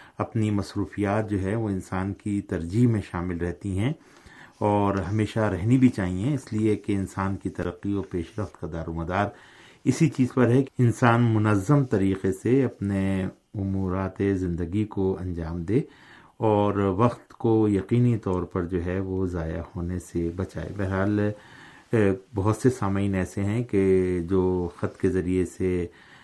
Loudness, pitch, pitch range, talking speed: -26 LUFS, 100 Hz, 90-110 Hz, 160 wpm